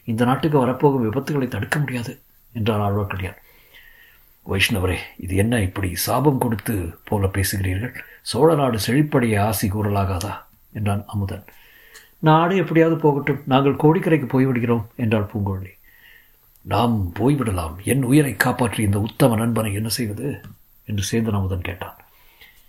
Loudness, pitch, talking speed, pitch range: -21 LUFS, 115 Hz, 120 wpm, 100-130 Hz